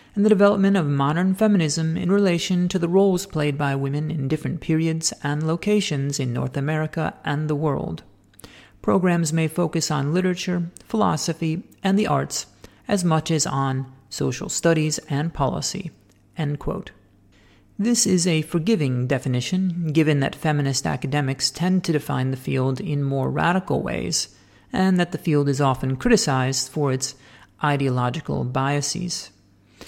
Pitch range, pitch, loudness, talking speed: 135-175 Hz, 150 Hz, -22 LUFS, 145 wpm